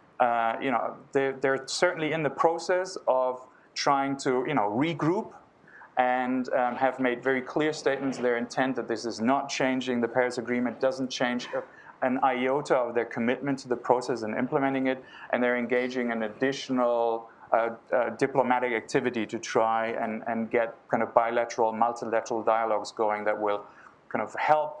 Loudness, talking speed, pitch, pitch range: -28 LUFS, 170 wpm, 125 Hz, 115-135 Hz